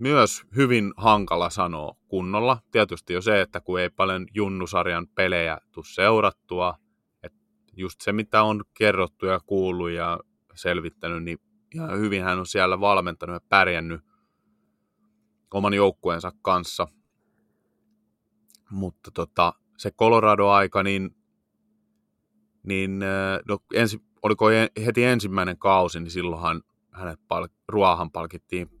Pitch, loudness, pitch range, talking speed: 95 Hz, -23 LUFS, 90-110 Hz, 115 wpm